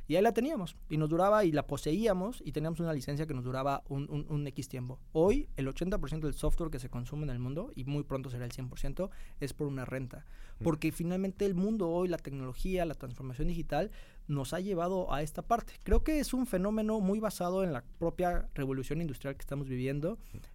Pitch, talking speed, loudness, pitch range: 155 Hz, 215 wpm, -34 LUFS, 140-185 Hz